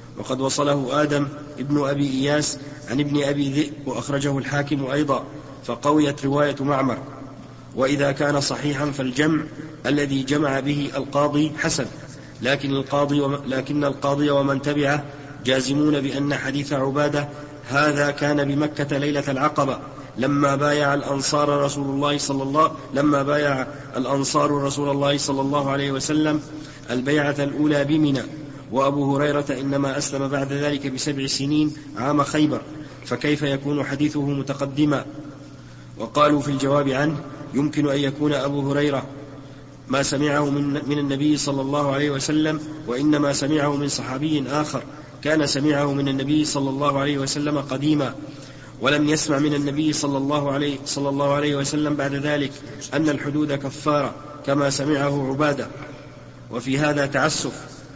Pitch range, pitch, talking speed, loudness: 140-145 Hz, 145 Hz, 130 wpm, -22 LUFS